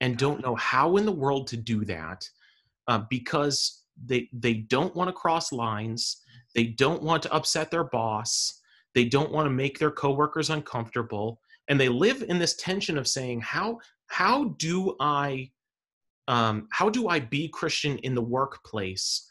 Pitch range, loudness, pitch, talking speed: 120-155 Hz, -27 LUFS, 135 Hz, 170 wpm